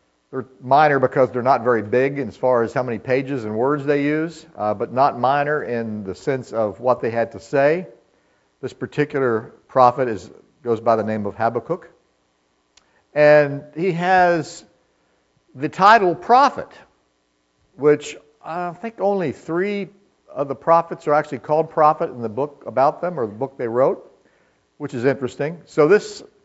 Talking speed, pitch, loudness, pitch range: 170 wpm, 140 Hz, -19 LUFS, 115-160 Hz